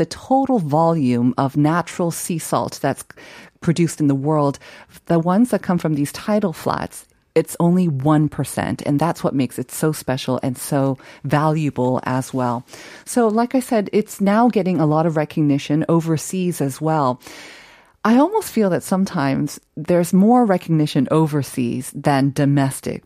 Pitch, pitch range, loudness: 155 Hz, 140-180 Hz, -19 LUFS